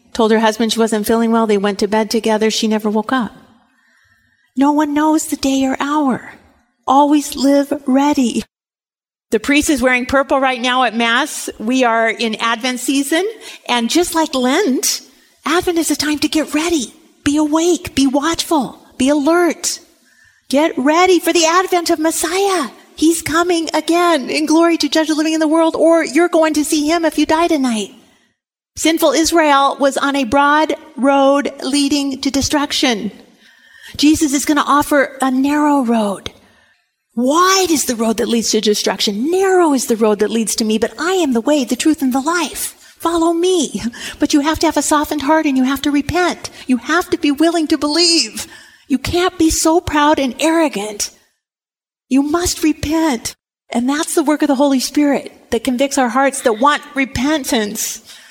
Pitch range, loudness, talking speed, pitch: 255-320 Hz, -15 LUFS, 180 wpm, 290 Hz